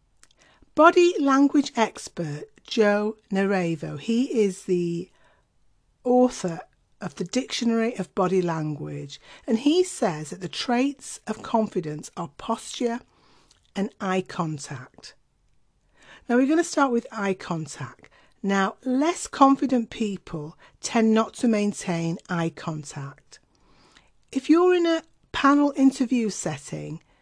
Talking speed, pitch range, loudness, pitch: 115 wpm, 175-260 Hz, -24 LUFS, 220 Hz